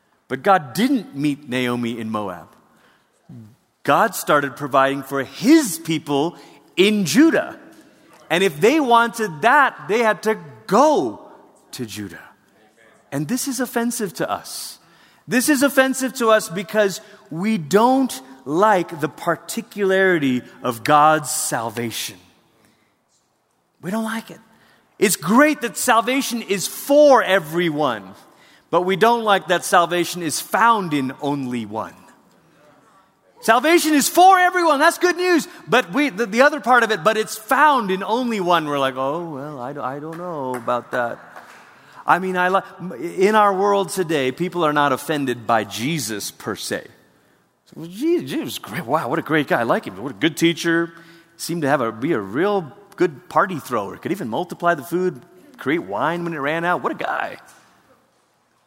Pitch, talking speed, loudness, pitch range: 180 Hz, 160 wpm, -19 LUFS, 145-230 Hz